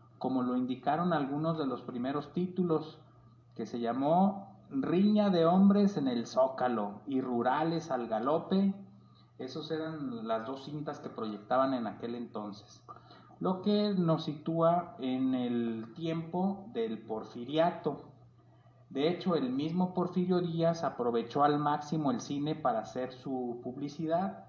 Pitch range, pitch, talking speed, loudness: 120-170 Hz, 145 Hz, 135 wpm, -32 LUFS